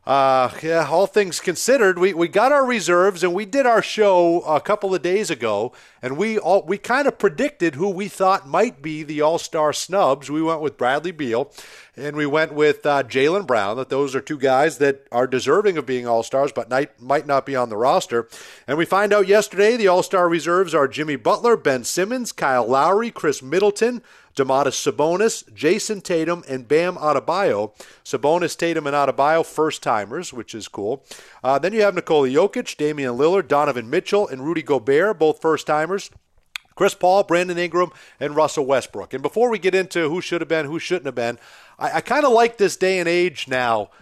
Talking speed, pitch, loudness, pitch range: 200 wpm, 170 Hz, -20 LUFS, 145-195 Hz